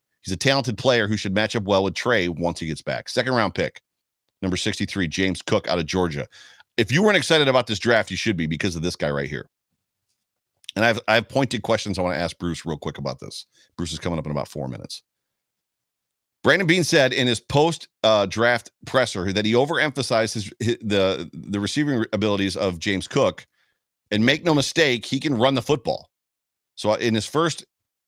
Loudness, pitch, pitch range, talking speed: -22 LUFS, 110 Hz, 90-125 Hz, 210 wpm